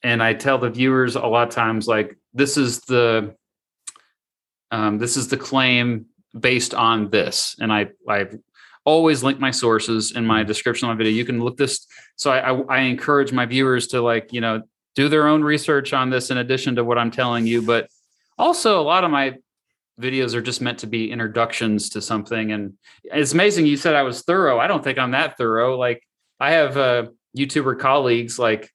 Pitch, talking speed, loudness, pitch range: 120 Hz, 200 wpm, -19 LUFS, 115-135 Hz